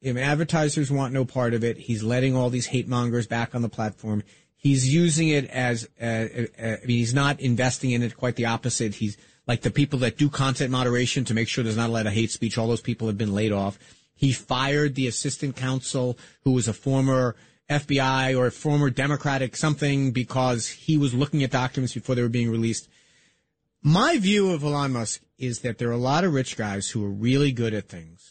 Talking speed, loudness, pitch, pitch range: 220 wpm, -24 LUFS, 125 Hz, 115-140 Hz